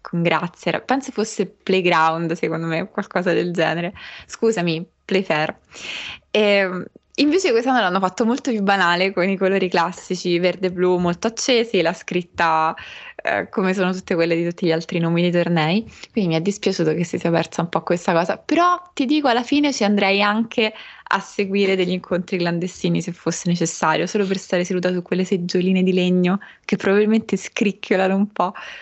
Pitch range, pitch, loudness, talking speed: 175-205 Hz, 185 Hz, -20 LUFS, 175 wpm